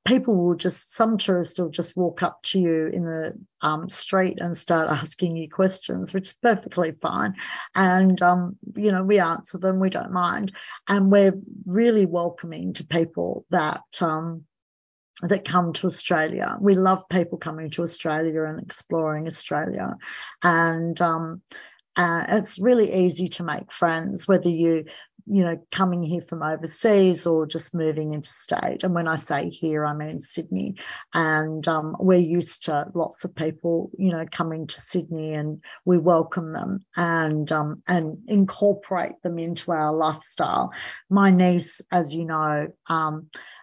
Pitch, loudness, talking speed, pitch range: 175 Hz, -23 LUFS, 160 wpm, 160-190 Hz